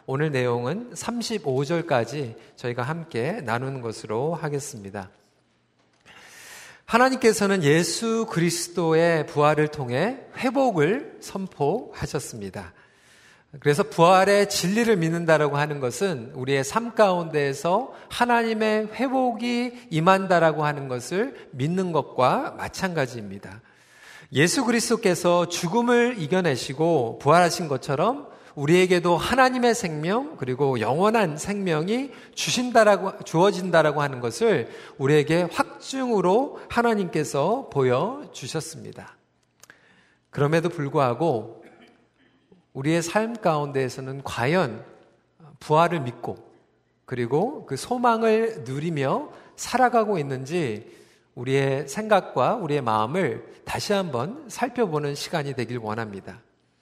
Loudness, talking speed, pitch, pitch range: -23 LUFS, 270 characters per minute, 165 Hz, 135-215 Hz